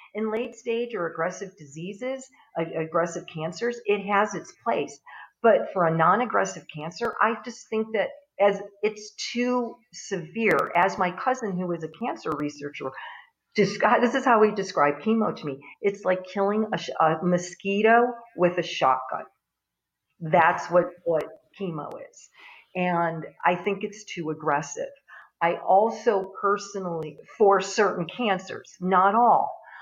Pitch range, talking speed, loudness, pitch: 170-220 Hz, 145 wpm, -25 LUFS, 195 Hz